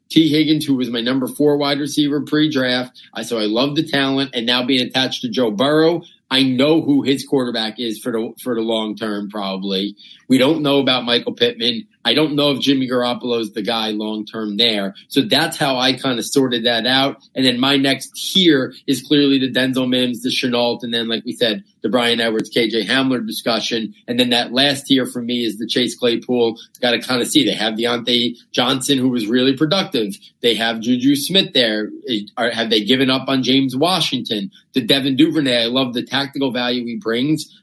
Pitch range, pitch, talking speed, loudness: 115-140 Hz, 130 Hz, 210 wpm, -17 LUFS